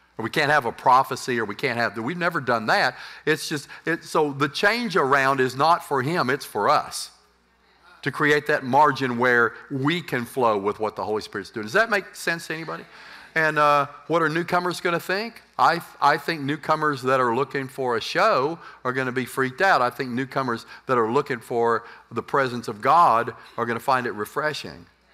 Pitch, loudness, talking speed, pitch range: 145 Hz, -23 LUFS, 210 wpm, 130-160 Hz